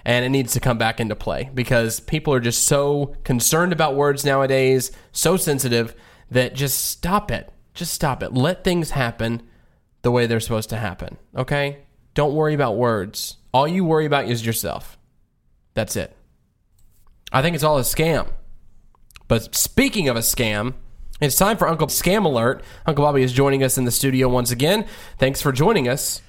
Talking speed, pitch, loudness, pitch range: 180 wpm, 130 Hz, -20 LUFS, 120-150 Hz